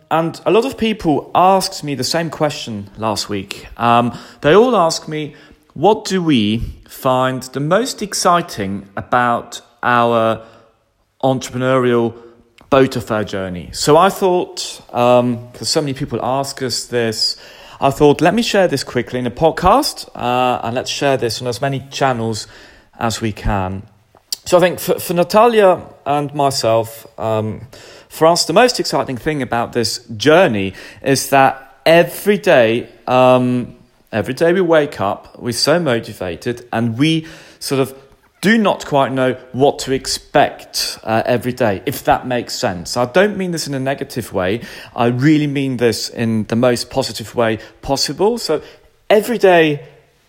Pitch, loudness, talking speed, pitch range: 130 Hz, -16 LUFS, 160 wpm, 115-155 Hz